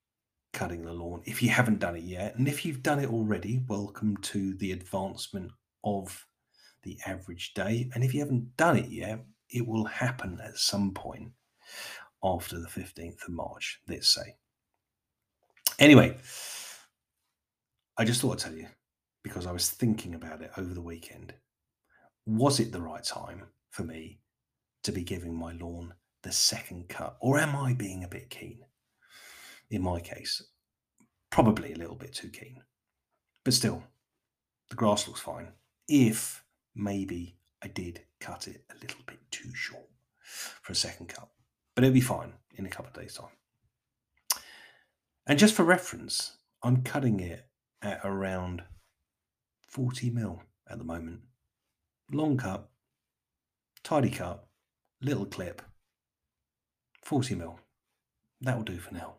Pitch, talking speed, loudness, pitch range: 105 Hz, 150 wpm, -30 LUFS, 90-120 Hz